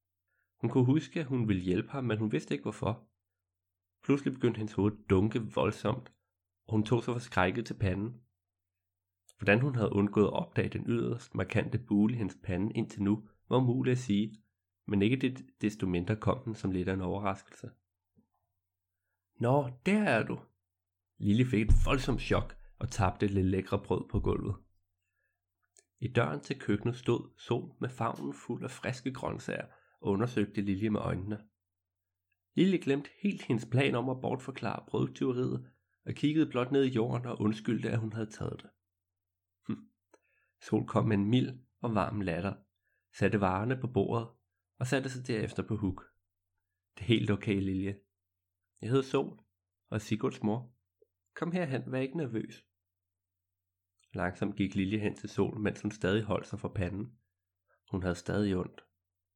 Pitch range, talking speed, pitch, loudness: 90-120 Hz, 170 wpm, 100 Hz, -33 LUFS